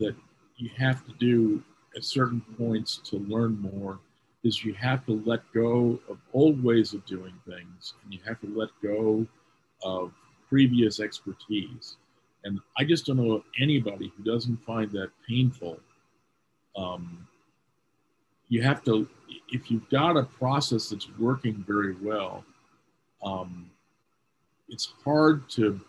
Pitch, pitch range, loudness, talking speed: 115 Hz, 100-125 Hz, -27 LUFS, 140 wpm